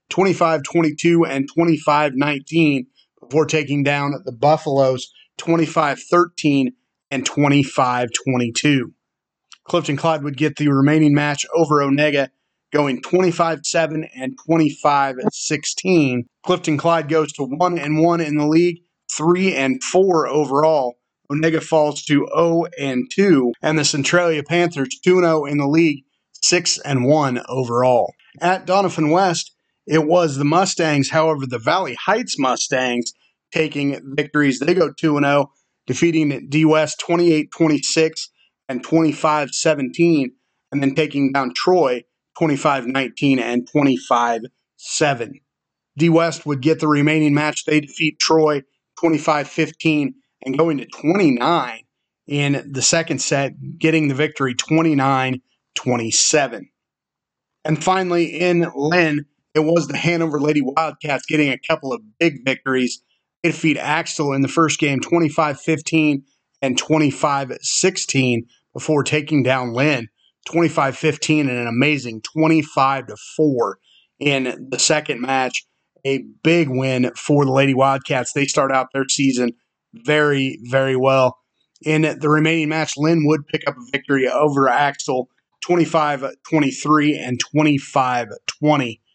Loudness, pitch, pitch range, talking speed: -18 LUFS, 150 Hz, 135-160 Hz, 130 wpm